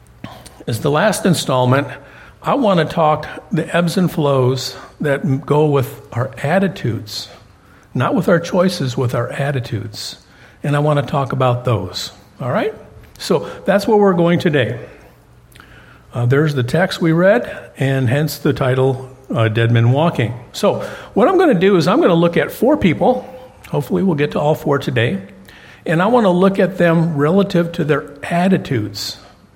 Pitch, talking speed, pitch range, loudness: 145 Hz, 175 wpm, 125-175 Hz, -16 LUFS